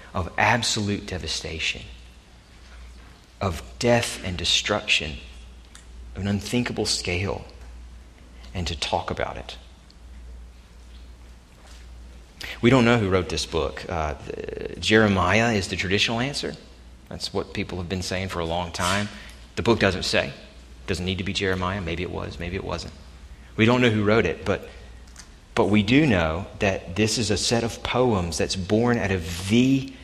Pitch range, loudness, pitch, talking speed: 65-105 Hz, -24 LUFS, 90 Hz, 160 wpm